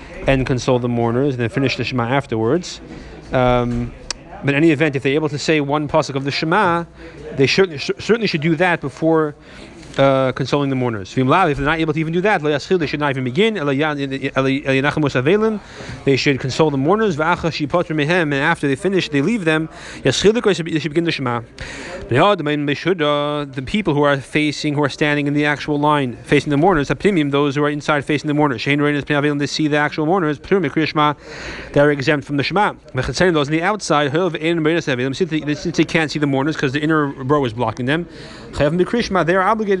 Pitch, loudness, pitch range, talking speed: 150 Hz, -18 LUFS, 140-165 Hz, 180 wpm